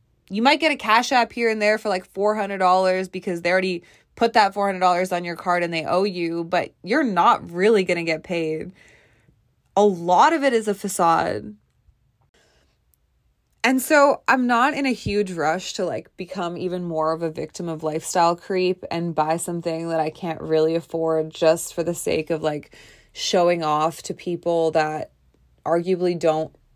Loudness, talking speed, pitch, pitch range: -21 LUFS, 180 wpm, 175 Hz, 160-195 Hz